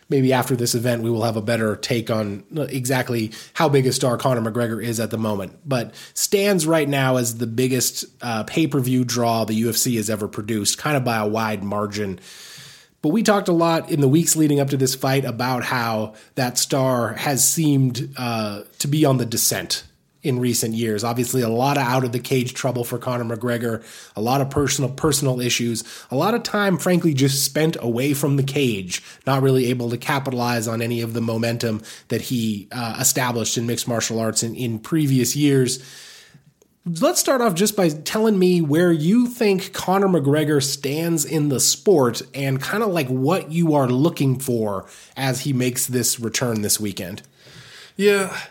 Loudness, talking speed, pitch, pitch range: -20 LUFS, 190 wpm, 130 Hz, 115-150 Hz